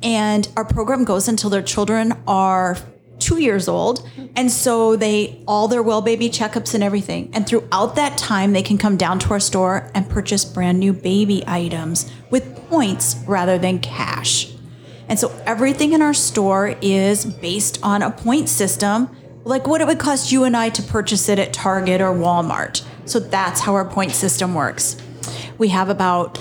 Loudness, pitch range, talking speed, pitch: -18 LUFS, 185-225 Hz, 180 wpm, 200 Hz